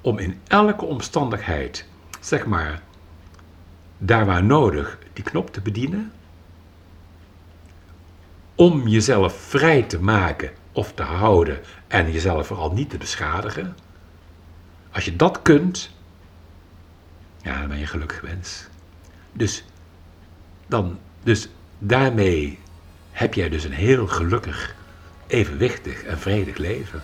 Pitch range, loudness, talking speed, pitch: 85-100 Hz, -21 LUFS, 115 wpm, 85 Hz